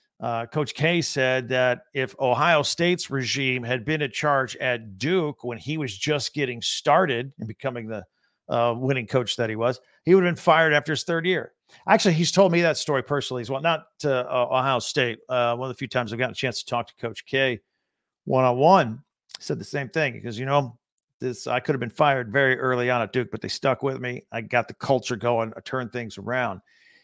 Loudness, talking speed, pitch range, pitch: -24 LUFS, 225 wpm, 120-145 Hz, 130 Hz